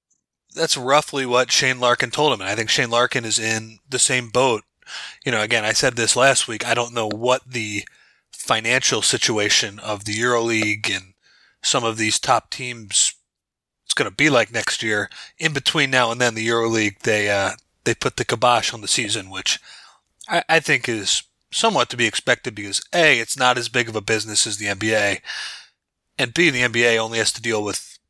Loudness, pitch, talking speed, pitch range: -19 LUFS, 115 Hz, 200 wpm, 110-125 Hz